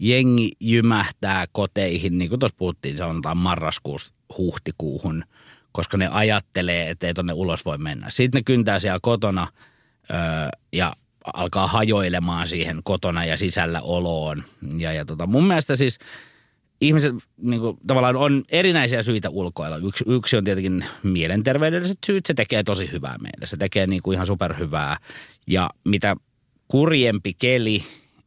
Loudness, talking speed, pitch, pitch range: -22 LUFS, 140 wpm, 100 Hz, 85-125 Hz